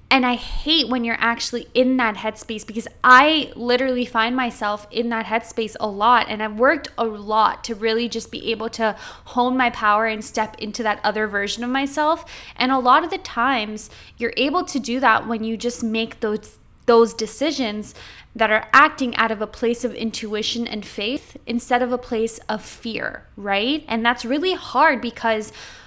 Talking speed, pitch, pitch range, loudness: 190 wpm, 230 Hz, 220-255 Hz, -20 LUFS